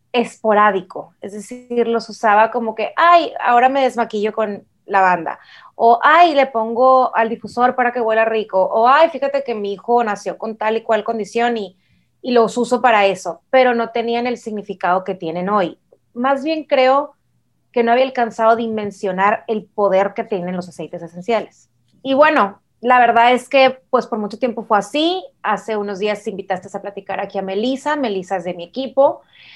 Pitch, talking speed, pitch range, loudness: 225 Hz, 190 wpm, 200-250 Hz, -17 LUFS